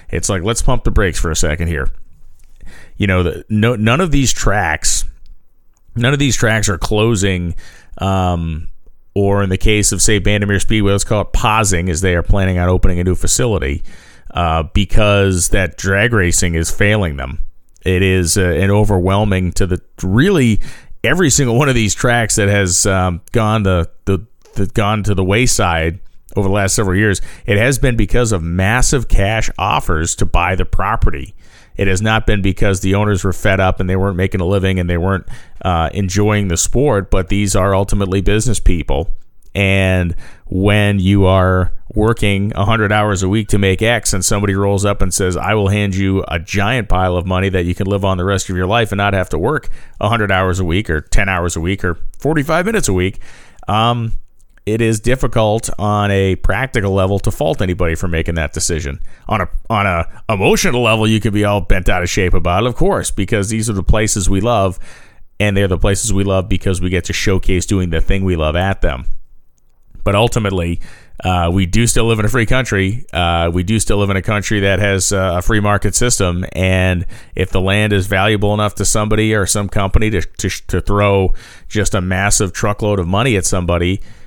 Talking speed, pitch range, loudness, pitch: 205 wpm, 90-105 Hz, -15 LUFS, 100 Hz